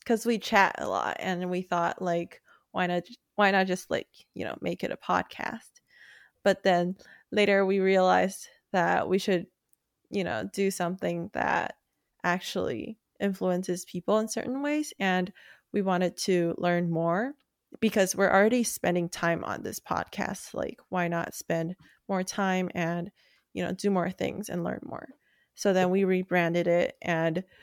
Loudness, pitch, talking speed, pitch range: -28 LUFS, 185 Hz, 165 wpm, 175-205 Hz